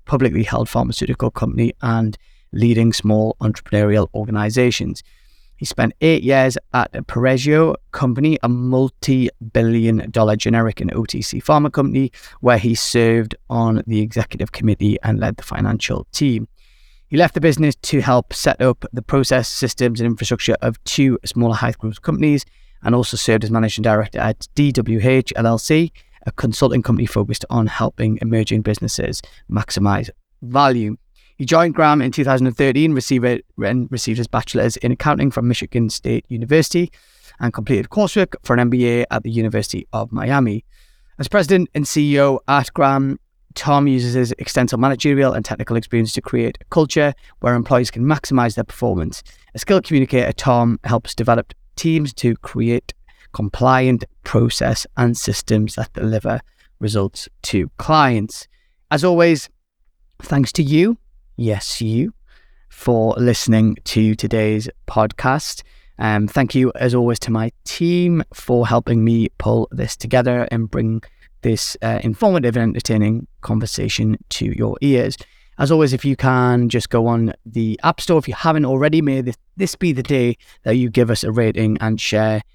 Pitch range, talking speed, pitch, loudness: 110-135 Hz, 155 wpm, 120 Hz, -18 LUFS